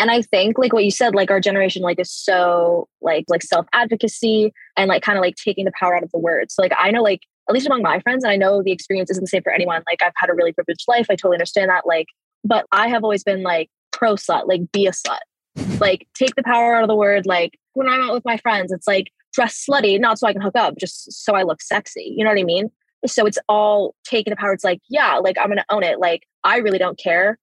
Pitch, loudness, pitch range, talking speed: 200 Hz, -18 LUFS, 180-230 Hz, 280 wpm